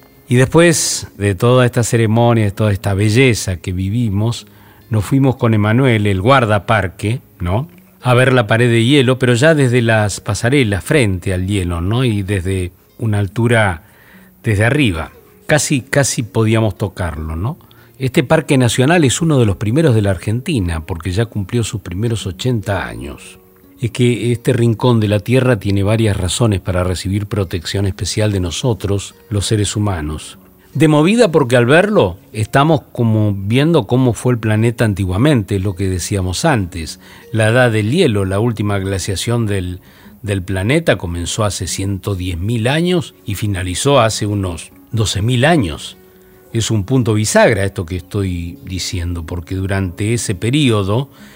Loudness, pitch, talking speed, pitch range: -15 LUFS, 105 Hz, 150 wpm, 95-125 Hz